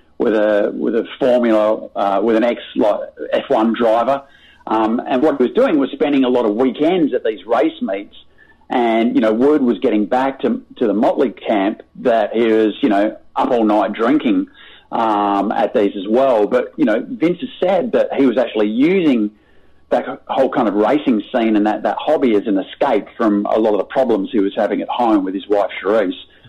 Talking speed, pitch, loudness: 210 wpm, 125 Hz, -16 LUFS